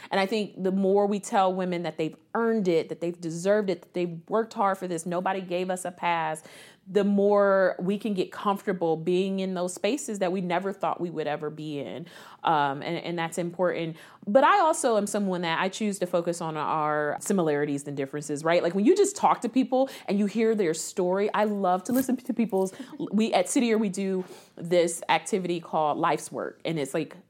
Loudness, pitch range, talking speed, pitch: -26 LUFS, 165-205 Hz, 215 wpm, 185 Hz